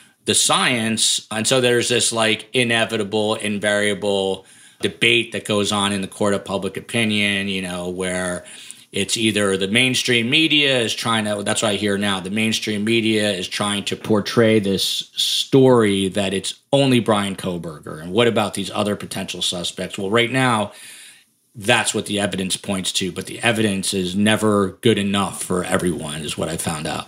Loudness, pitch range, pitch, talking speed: -19 LUFS, 95-115 Hz, 105 Hz, 175 wpm